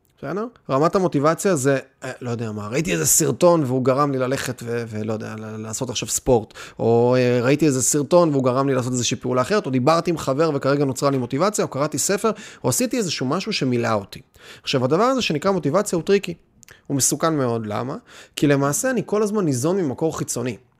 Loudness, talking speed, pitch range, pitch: -20 LUFS, 190 wpm, 125-175 Hz, 140 Hz